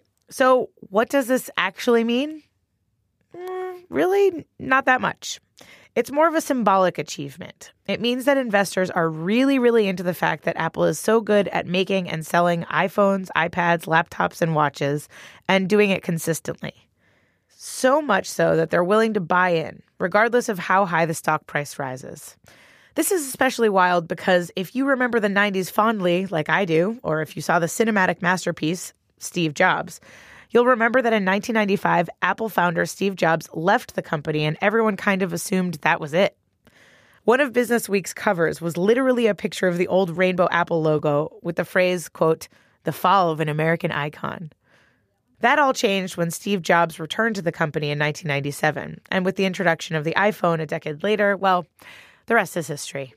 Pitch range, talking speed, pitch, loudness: 165-220 Hz, 175 wpm, 185 Hz, -21 LUFS